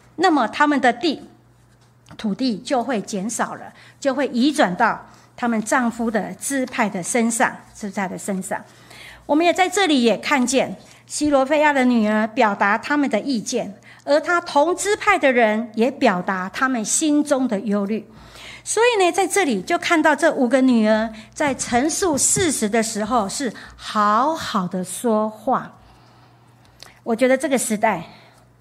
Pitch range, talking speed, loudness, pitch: 215-295 Hz, 225 characters per minute, -19 LUFS, 240 Hz